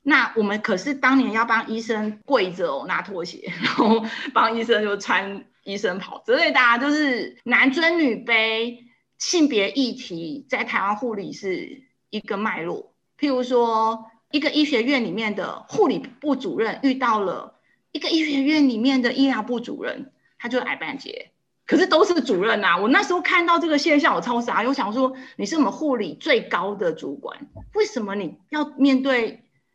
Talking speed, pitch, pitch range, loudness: 260 characters per minute, 255 Hz, 225-295 Hz, -21 LUFS